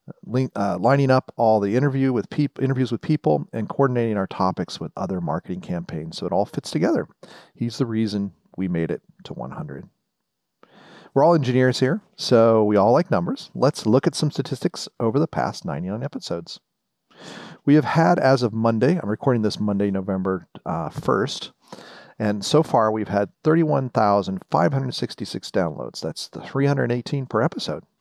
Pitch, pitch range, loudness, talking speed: 120 Hz, 105-140 Hz, -22 LUFS, 165 wpm